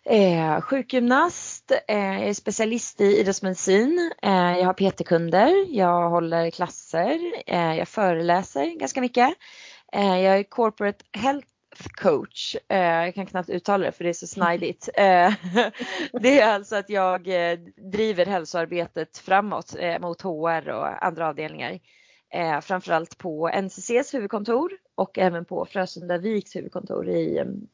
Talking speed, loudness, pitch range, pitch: 140 wpm, -23 LUFS, 175-220 Hz, 190 Hz